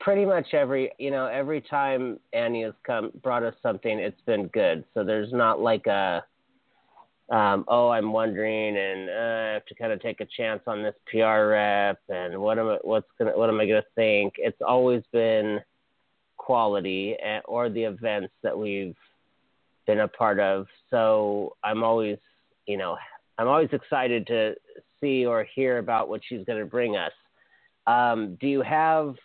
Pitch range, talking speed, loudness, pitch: 105-130 Hz, 175 wpm, -26 LUFS, 110 Hz